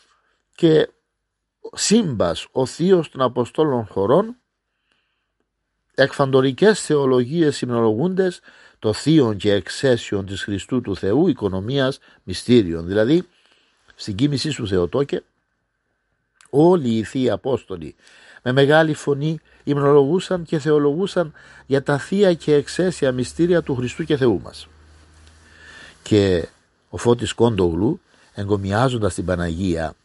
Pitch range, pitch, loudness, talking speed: 100-155 Hz, 130 Hz, -19 LUFS, 105 wpm